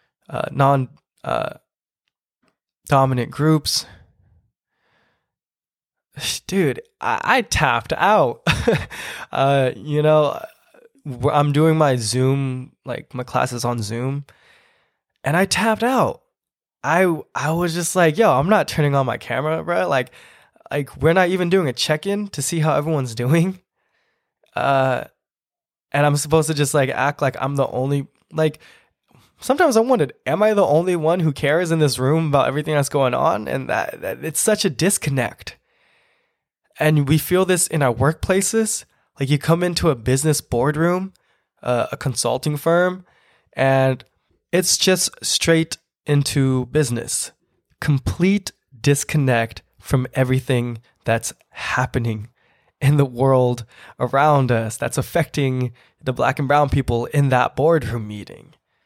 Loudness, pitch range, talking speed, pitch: -19 LUFS, 130-165 Hz, 140 wpm, 145 Hz